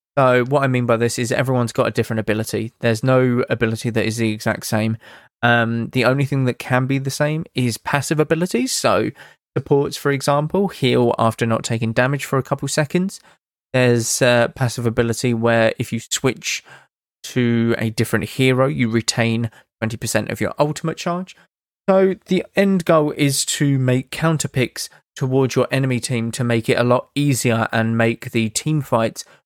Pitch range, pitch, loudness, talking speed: 115-145 Hz, 125 Hz, -19 LUFS, 180 wpm